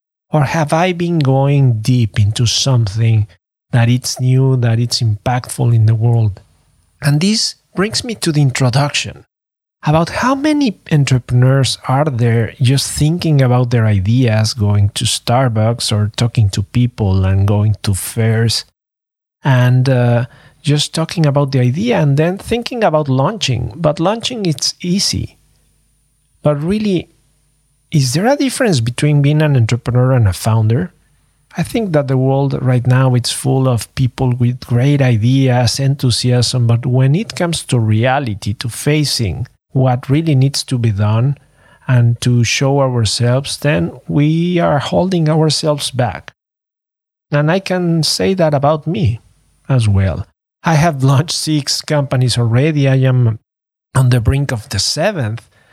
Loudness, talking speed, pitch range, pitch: -14 LUFS, 150 wpm, 120-150 Hz, 130 Hz